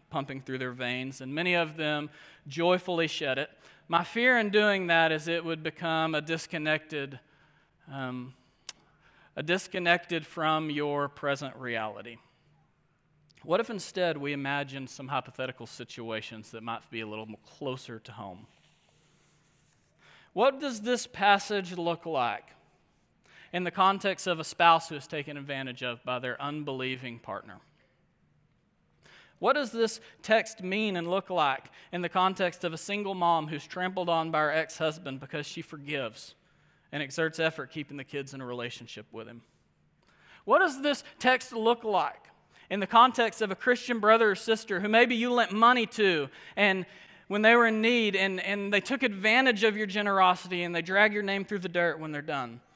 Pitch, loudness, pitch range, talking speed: 165 Hz, -28 LUFS, 140-200 Hz, 165 wpm